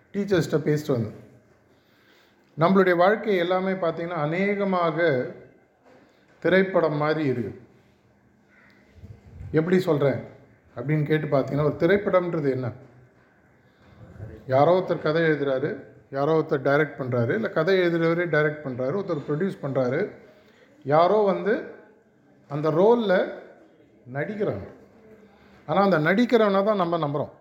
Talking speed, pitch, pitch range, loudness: 100 wpm, 155 Hz, 135-185 Hz, -23 LUFS